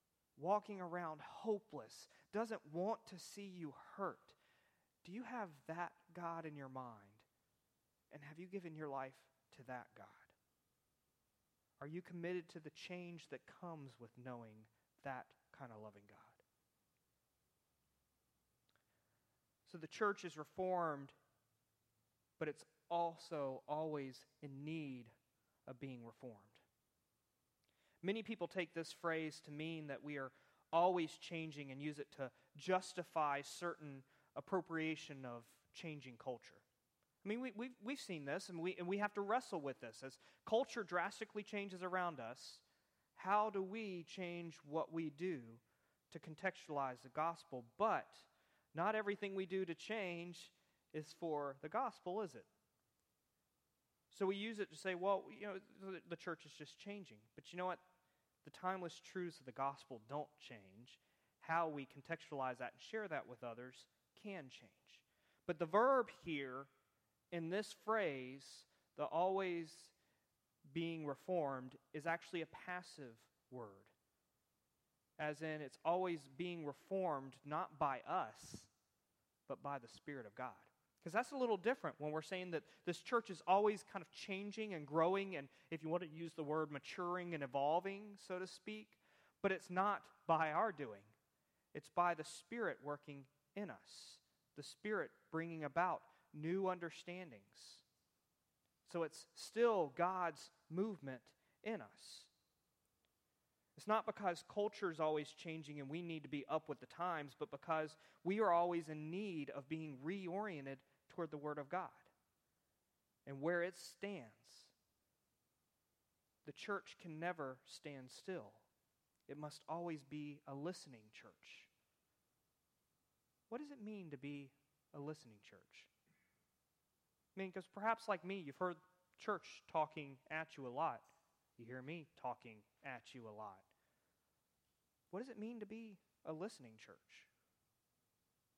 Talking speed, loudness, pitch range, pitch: 145 wpm, -45 LUFS, 140-185 Hz, 160 Hz